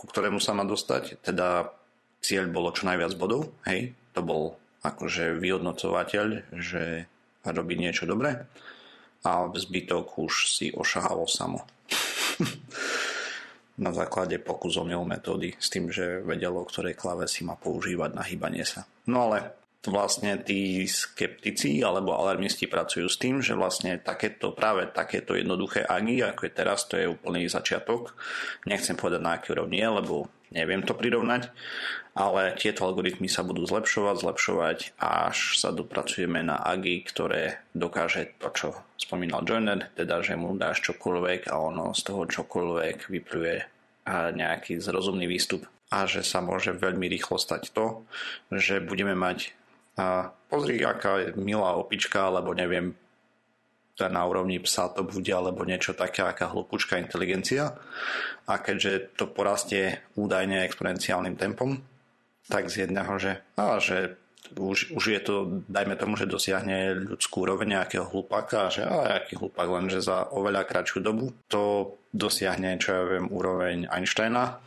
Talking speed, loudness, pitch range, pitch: 145 wpm, -28 LUFS, 90-105 Hz, 95 Hz